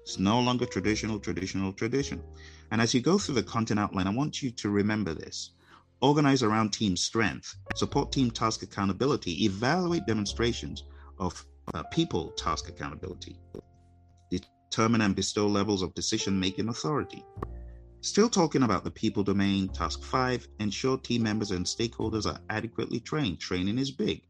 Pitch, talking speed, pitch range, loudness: 100 Hz, 155 wpm, 90-115 Hz, -29 LUFS